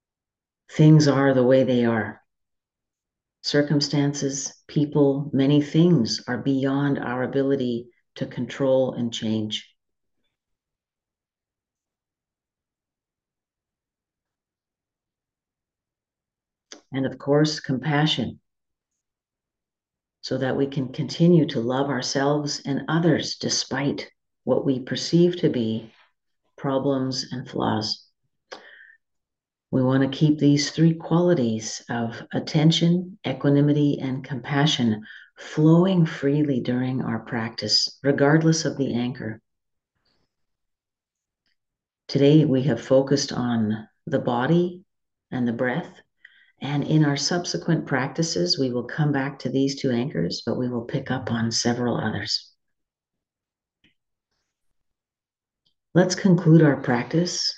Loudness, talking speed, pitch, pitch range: -22 LUFS, 100 wpm, 135 Hz, 120-150 Hz